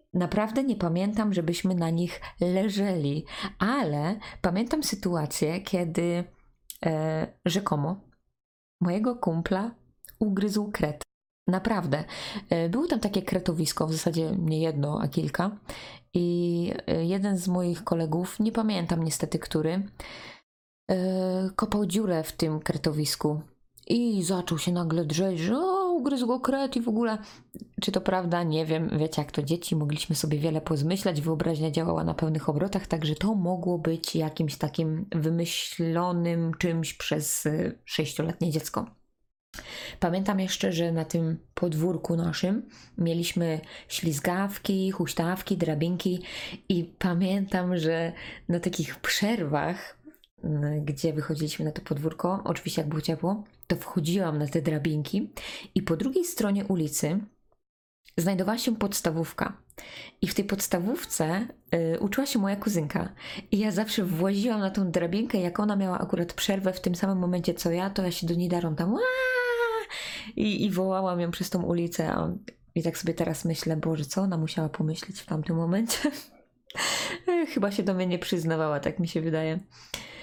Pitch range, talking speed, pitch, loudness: 165-200 Hz, 140 wpm, 175 Hz, -28 LUFS